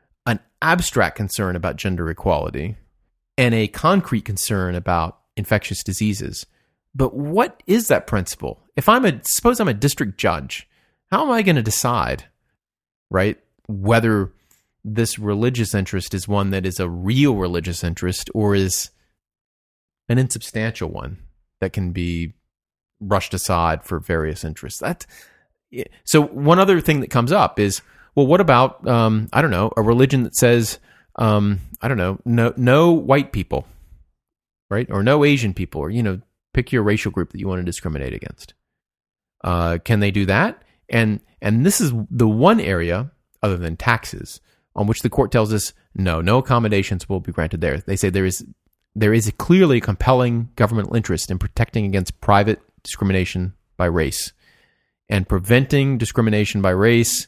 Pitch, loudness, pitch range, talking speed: 105 Hz, -19 LUFS, 95-120 Hz, 165 wpm